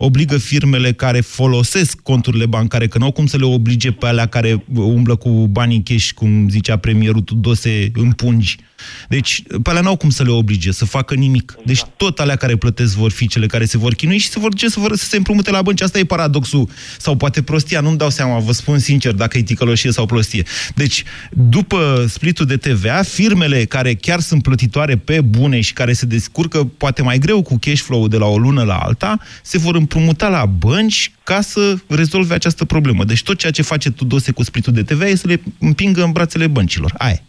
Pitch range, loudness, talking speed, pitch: 115-160 Hz, -14 LUFS, 215 wpm, 130 Hz